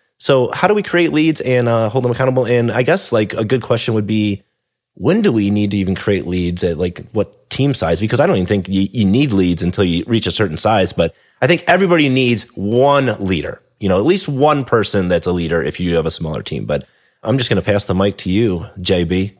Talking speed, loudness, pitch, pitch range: 250 wpm, -15 LUFS, 105 Hz, 95-125 Hz